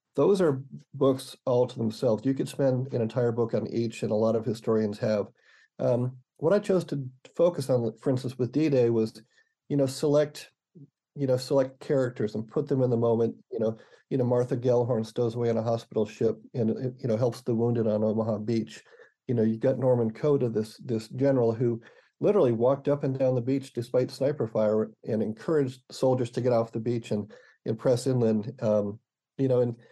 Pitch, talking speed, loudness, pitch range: 125 Hz, 205 wpm, -27 LUFS, 115-135 Hz